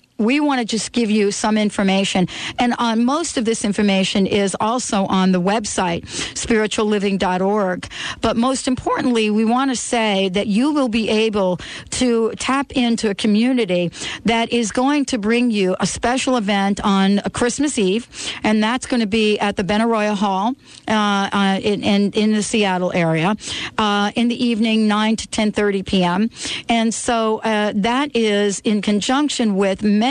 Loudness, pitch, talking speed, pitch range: -18 LUFS, 215 Hz, 165 wpm, 200-235 Hz